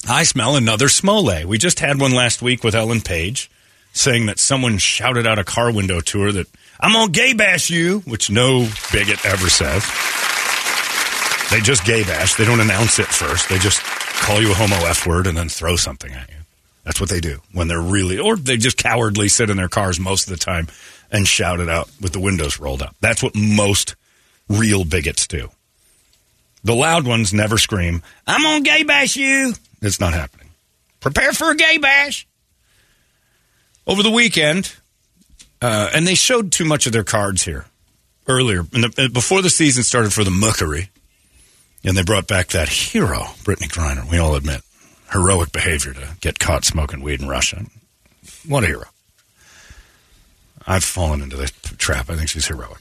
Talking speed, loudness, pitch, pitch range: 185 wpm, -16 LUFS, 100 Hz, 85-125 Hz